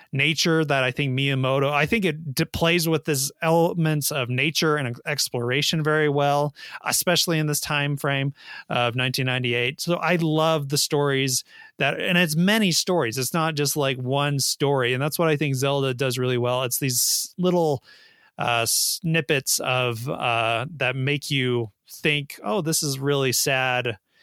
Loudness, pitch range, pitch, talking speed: -22 LUFS, 130-160 Hz, 145 Hz, 165 wpm